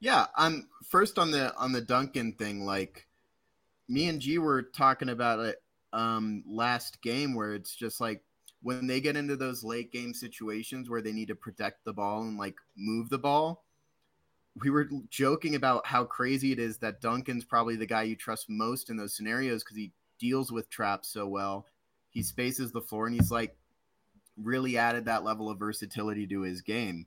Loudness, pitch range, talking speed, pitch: -31 LUFS, 105-130 Hz, 195 wpm, 115 Hz